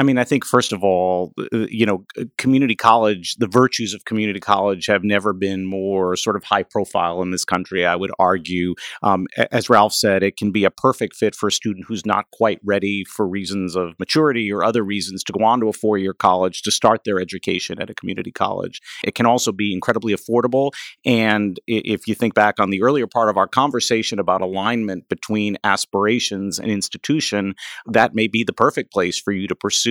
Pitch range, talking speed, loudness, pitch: 95-115 Hz, 210 wpm, -19 LUFS, 105 Hz